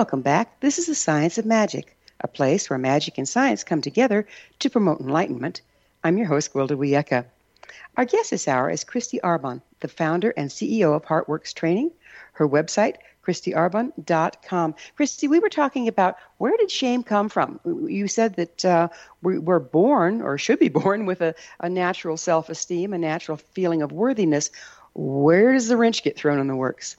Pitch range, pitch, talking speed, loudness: 155-230 Hz, 175 Hz, 180 wpm, -22 LUFS